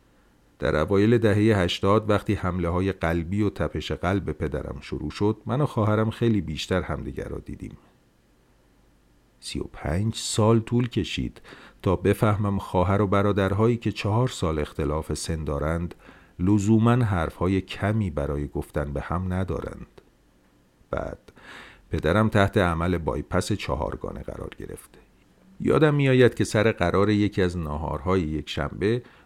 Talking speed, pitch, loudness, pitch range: 135 wpm, 95 Hz, -25 LUFS, 75-105 Hz